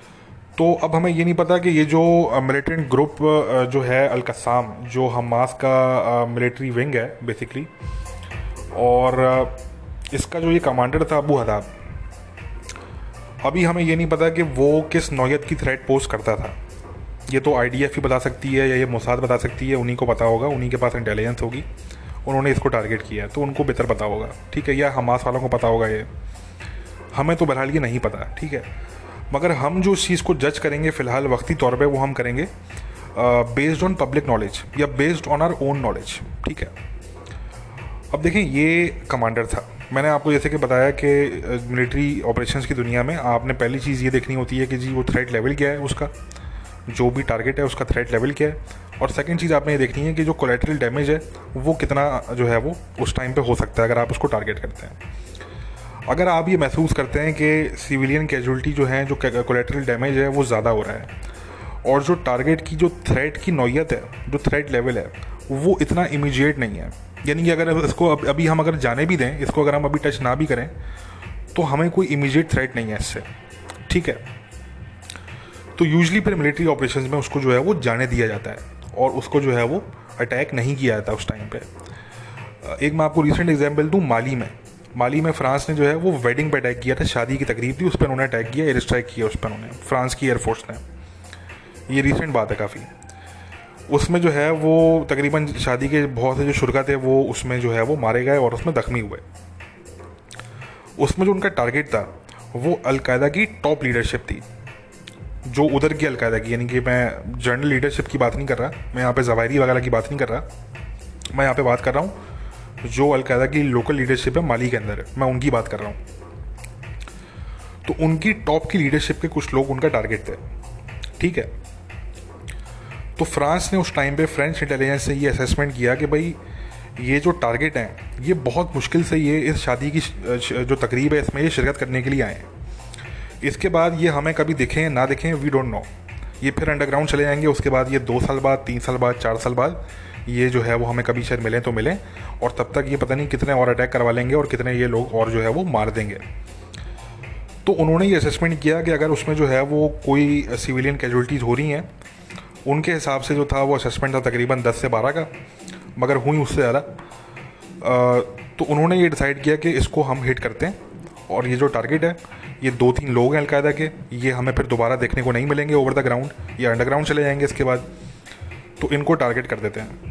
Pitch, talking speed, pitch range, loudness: 130 Hz, 210 wpm, 120-150 Hz, -20 LUFS